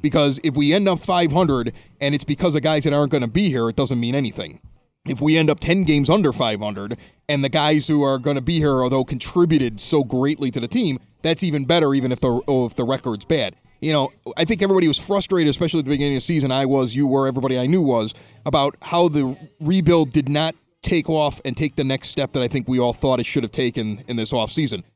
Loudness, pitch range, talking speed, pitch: -20 LUFS, 130-155 Hz, 250 wpm, 145 Hz